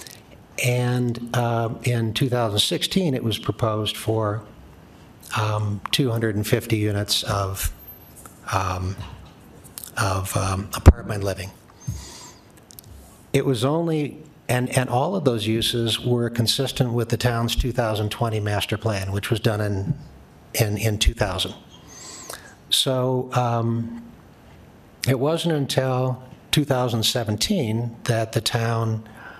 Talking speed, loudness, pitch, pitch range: 100 wpm, -23 LUFS, 115 Hz, 105-125 Hz